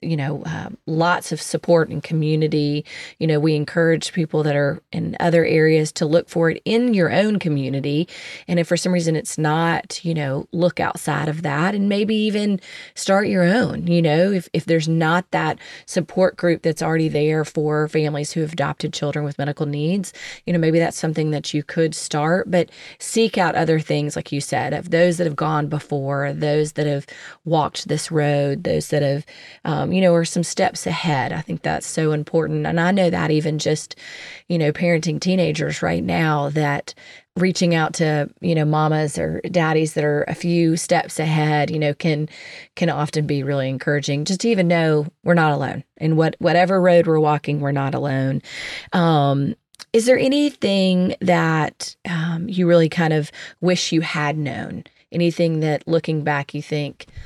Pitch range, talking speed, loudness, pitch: 150-175 Hz, 190 wpm, -20 LUFS, 160 Hz